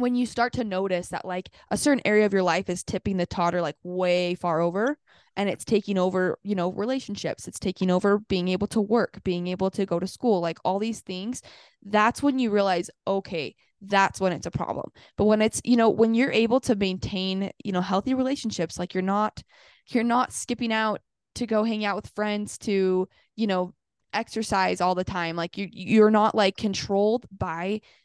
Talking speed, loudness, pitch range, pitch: 205 wpm, -25 LUFS, 185-220 Hz, 200 Hz